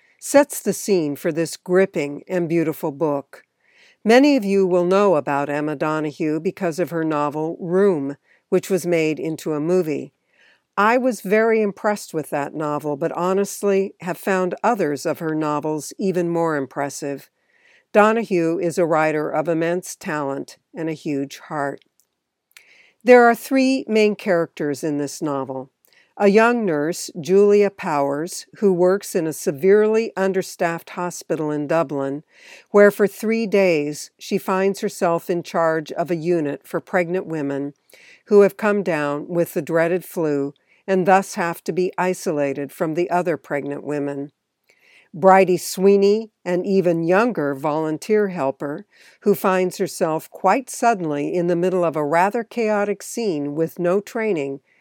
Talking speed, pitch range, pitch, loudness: 150 wpm, 155-200 Hz, 175 Hz, -20 LUFS